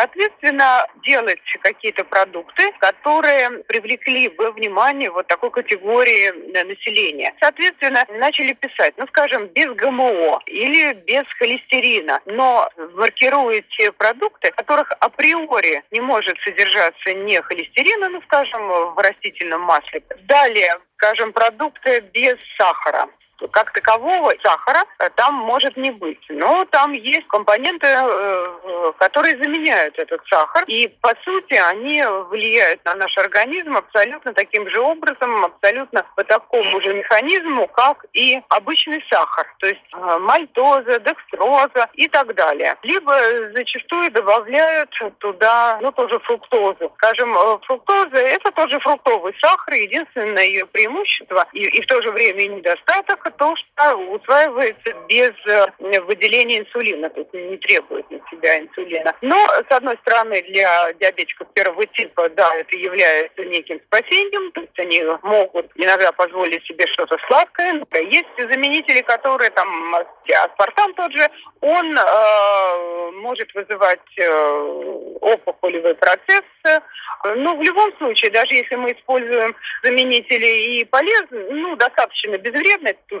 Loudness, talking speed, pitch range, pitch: -16 LUFS, 125 wpm, 205-330 Hz, 255 Hz